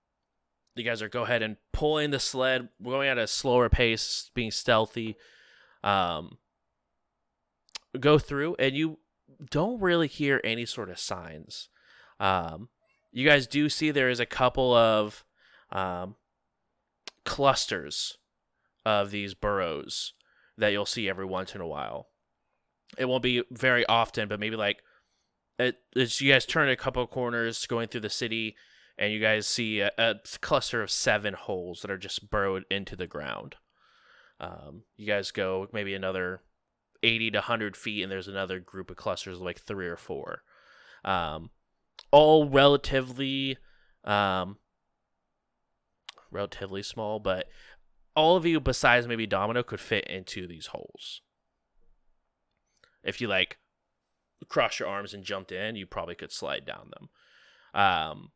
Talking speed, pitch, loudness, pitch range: 150 wpm, 110 Hz, -28 LUFS, 100-130 Hz